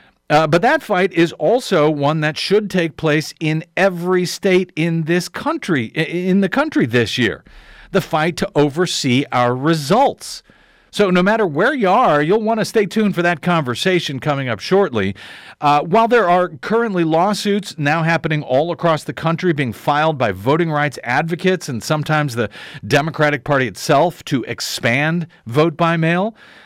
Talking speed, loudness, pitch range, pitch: 165 wpm, -17 LUFS, 145-185 Hz, 165 Hz